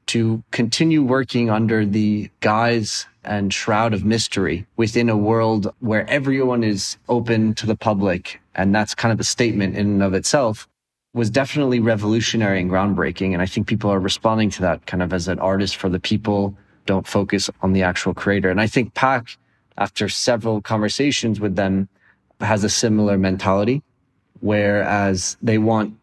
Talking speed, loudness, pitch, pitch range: 170 wpm, -19 LUFS, 105 Hz, 100-115 Hz